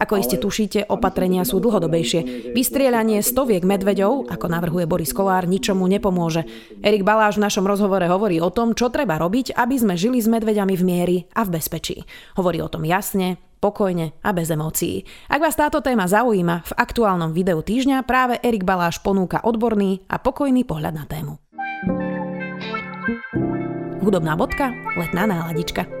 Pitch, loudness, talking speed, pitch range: 195 Hz, -20 LUFS, 155 wpm, 175-225 Hz